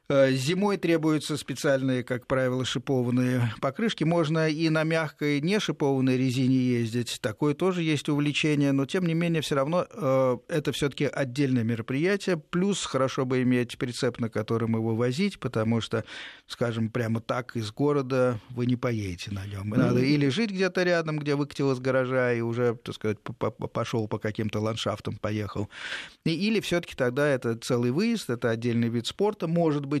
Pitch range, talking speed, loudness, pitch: 120-155 Hz, 160 wpm, -27 LUFS, 135 Hz